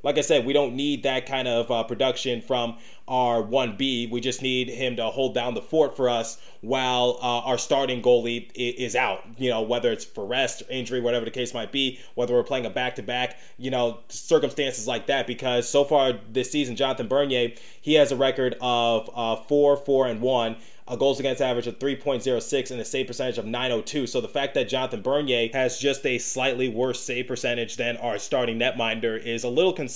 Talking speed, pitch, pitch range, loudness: 210 wpm, 125 Hz, 120-130 Hz, -25 LUFS